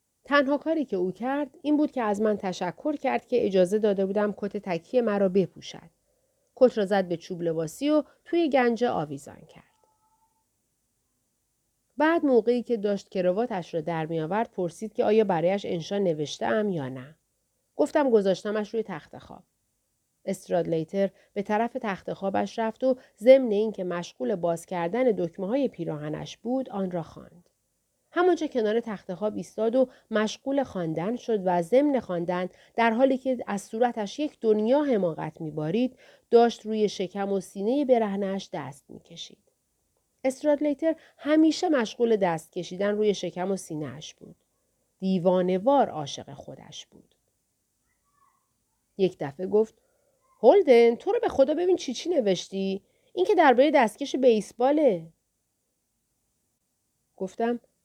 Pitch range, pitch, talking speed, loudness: 185-265 Hz, 215 Hz, 140 wpm, -26 LUFS